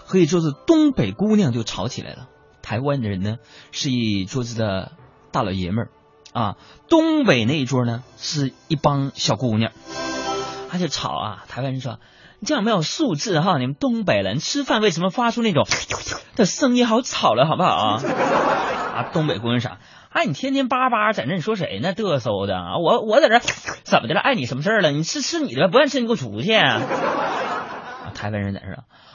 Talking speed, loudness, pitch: 290 characters per minute, -20 LUFS, 145 Hz